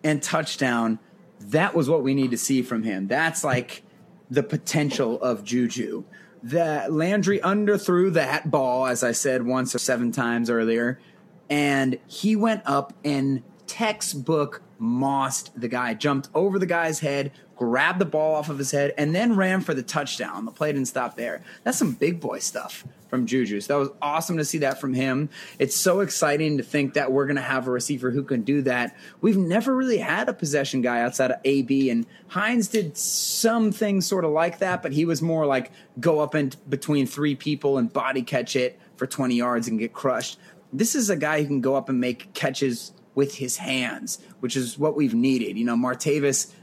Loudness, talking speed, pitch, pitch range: -24 LUFS, 200 wpm, 145 Hz, 130-170 Hz